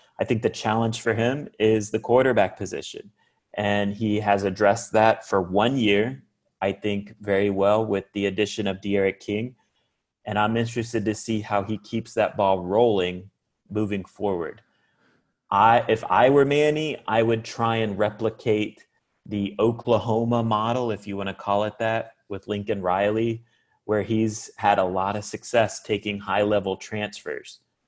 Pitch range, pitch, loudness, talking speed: 100-115 Hz, 105 Hz, -24 LUFS, 160 wpm